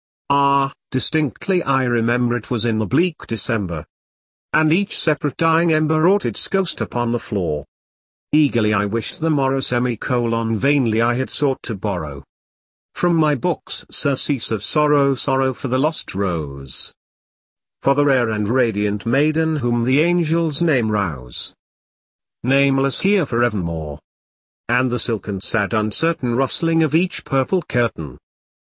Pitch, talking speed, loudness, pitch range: 120 Hz, 140 wpm, -20 LUFS, 100-150 Hz